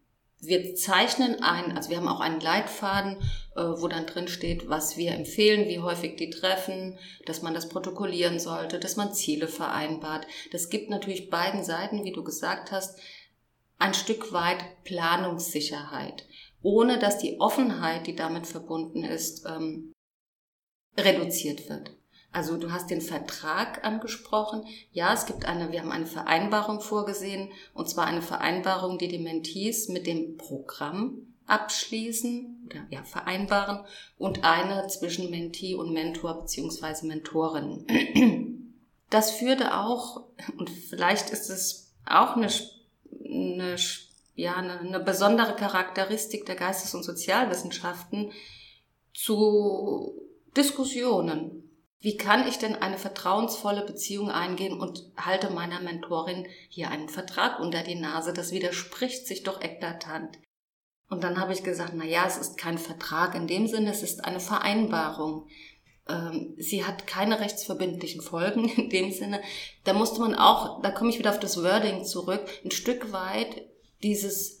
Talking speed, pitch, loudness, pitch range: 140 wpm, 185 Hz, -28 LUFS, 170-210 Hz